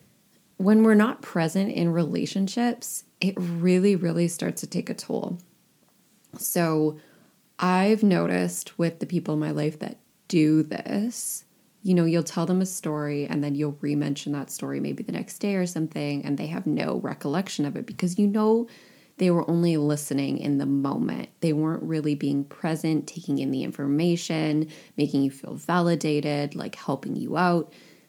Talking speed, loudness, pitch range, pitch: 170 wpm, -26 LUFS, 150-195 Hz, 170 Hz